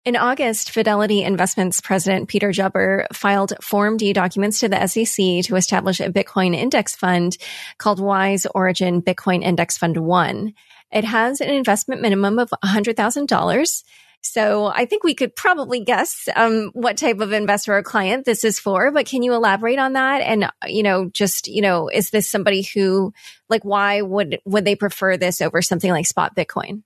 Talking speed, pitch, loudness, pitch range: 175 wpm, 205 Hz, -18 LUFS, 190-225 Hz